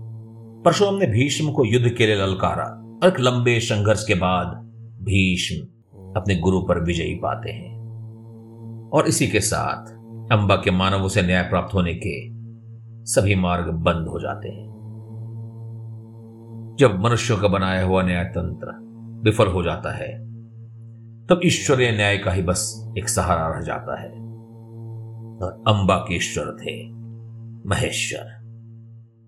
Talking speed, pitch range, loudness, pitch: 135 wpm, 95-115 Hz, -21 LUFS, 115 Hz